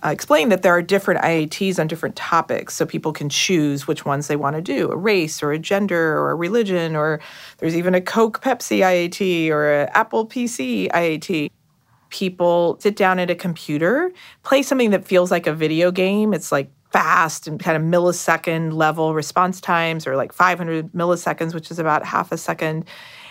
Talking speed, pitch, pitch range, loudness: 190 wpm, 170 Hz, 155-190 Hz, -19 LUFS